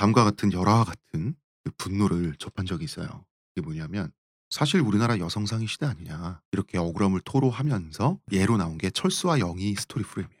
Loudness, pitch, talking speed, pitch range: -27 LUFS, 105 Hz, 410 characters per minute, 95-135 Hz